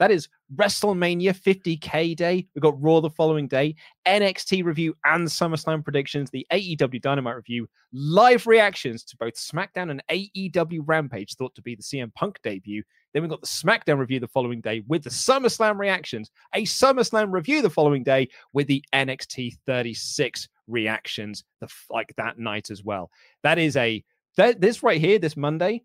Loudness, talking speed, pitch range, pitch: -23 LUFS, 165 wpm, 125-180 Hz, 150 Hz